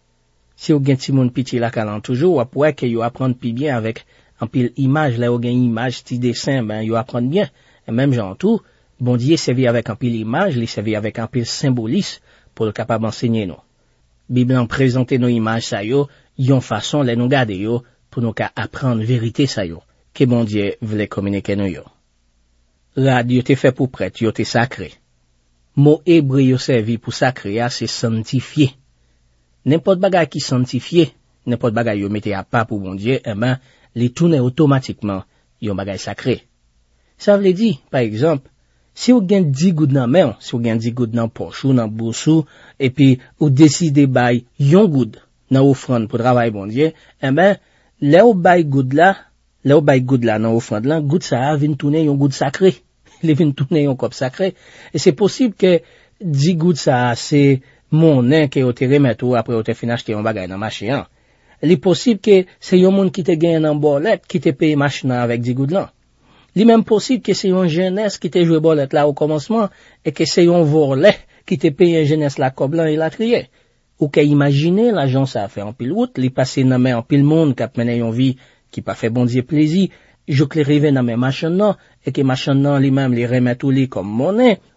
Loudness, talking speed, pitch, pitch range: -16 LUFS, 205 wpm, 130 Hz, 115-155 Hz